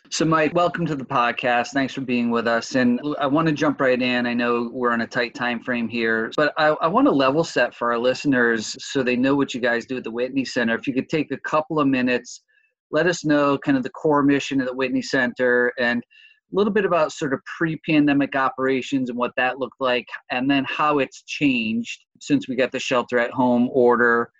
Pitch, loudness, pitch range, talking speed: 130 Hz, -21 LUFS, 120-150 Hz, 235 wpm